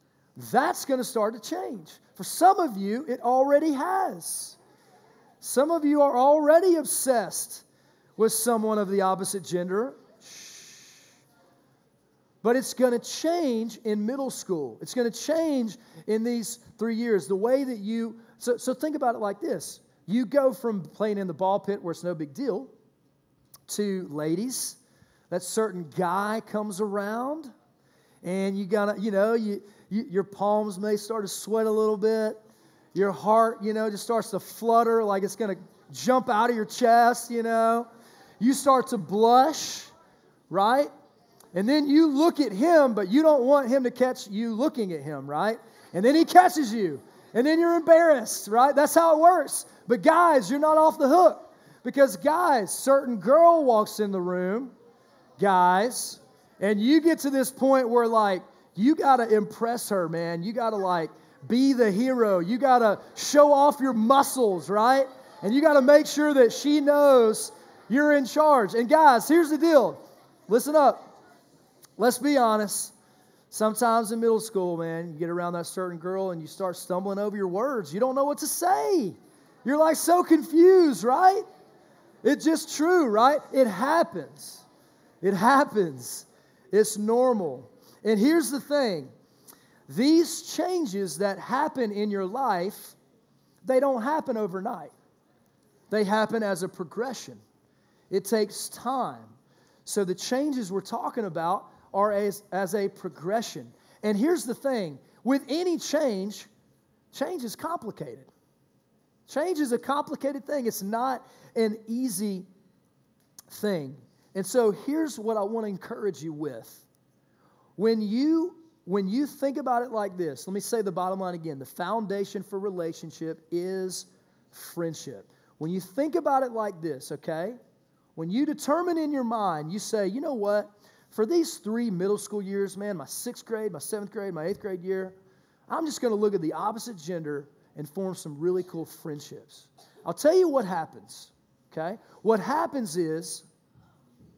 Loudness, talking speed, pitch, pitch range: -25 LUFS, 165 wpm, 225 Hz, 195-275 Hz